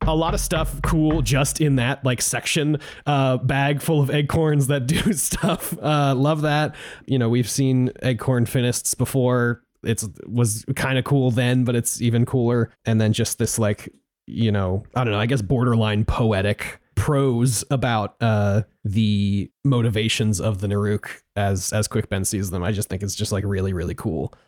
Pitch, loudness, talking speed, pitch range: 120 Hz, -21 LUFS, 185 wpm, 105-140 Hz